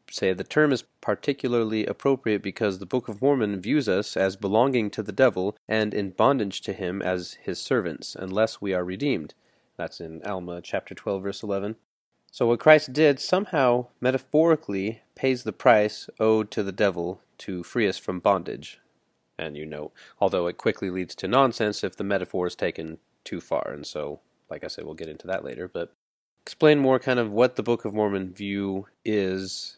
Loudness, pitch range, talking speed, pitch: -25 LUFS, 95-125 Hz, 185 wpm, 105 Hz